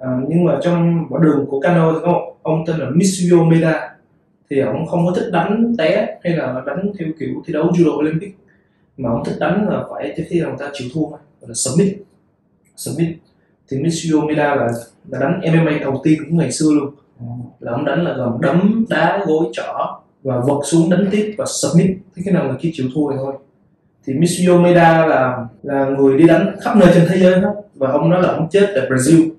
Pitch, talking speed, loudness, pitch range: 165 Hz, 215 wpm, -16 LUFS, 140-175 Hz